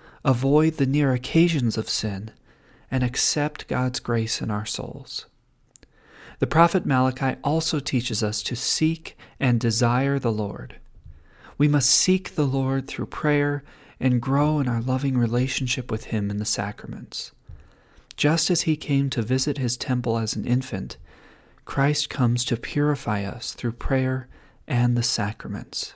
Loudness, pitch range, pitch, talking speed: -24 LUFS, 120-145 Hz, 130 Hz, 150 wpm